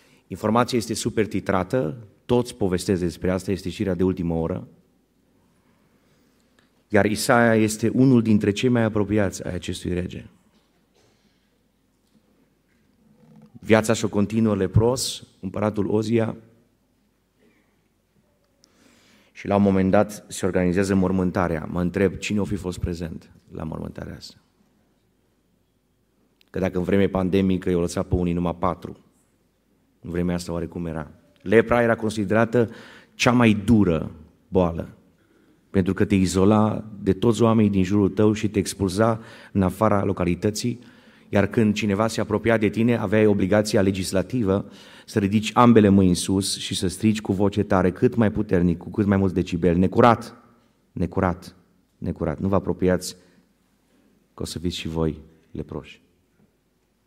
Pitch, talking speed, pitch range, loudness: 100 Hz, 135 wpm, 90-110 Hz, -22 LUFS